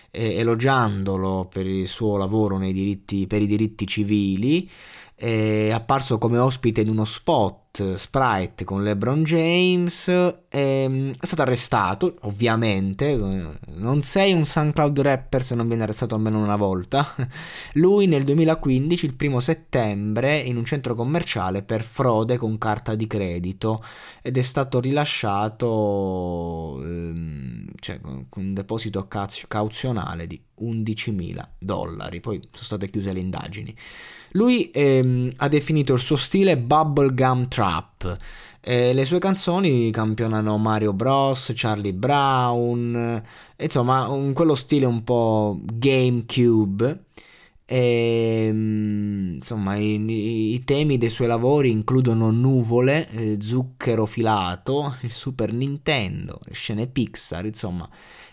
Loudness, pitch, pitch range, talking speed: -22 LUFS, 115 Hz, 105-135 Hz, 120 wpm